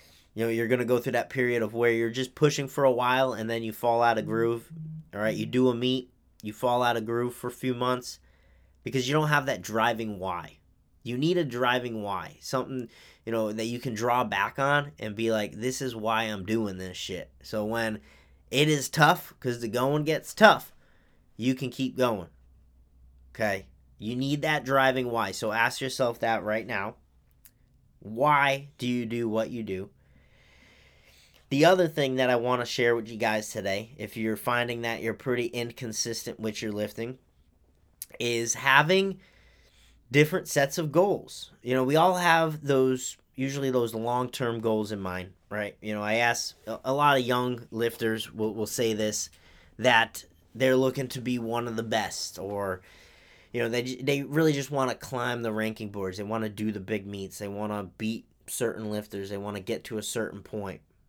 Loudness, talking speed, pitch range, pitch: -28 LUFS, 195 wpm, 105-130 Hz, 115 Hz